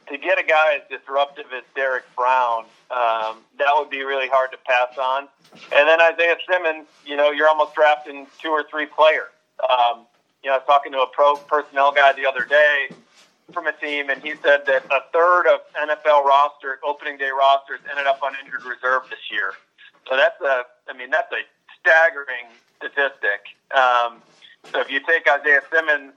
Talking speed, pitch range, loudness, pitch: 190 wpm, 135-155 Hz, -19 LUFS, 145 Hz